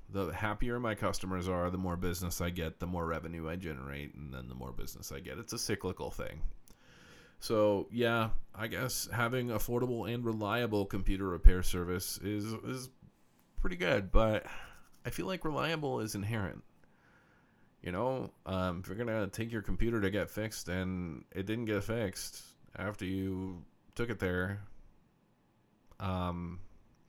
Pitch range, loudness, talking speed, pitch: 90-115 Hz, -36 LUFS, 155 wpm, 100 Hz